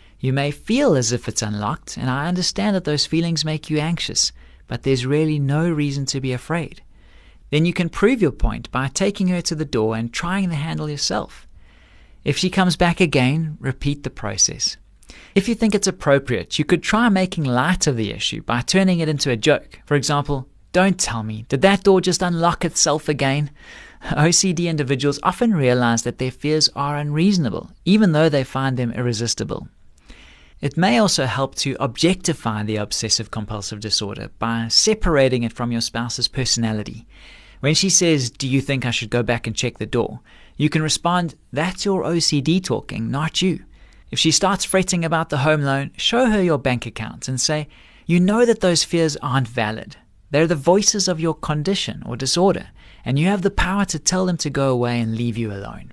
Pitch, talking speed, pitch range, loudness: 145 Hz, 195 wpm, 120-175 Hz, -19 LUFS